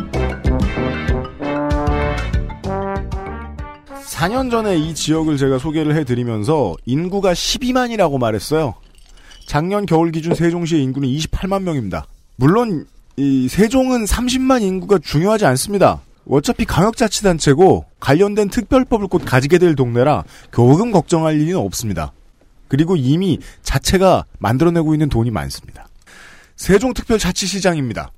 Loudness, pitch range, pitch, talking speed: -17 LUFS, 120-195 Hz, 155 Hz, 280 characters per minute